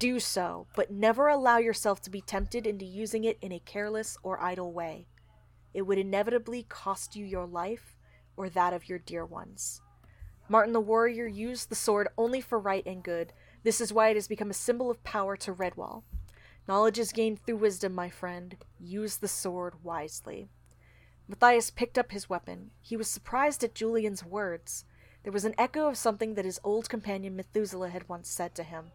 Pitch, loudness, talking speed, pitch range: 205 Hz, -31 LUFS, 190 wpm, 180-225 Hz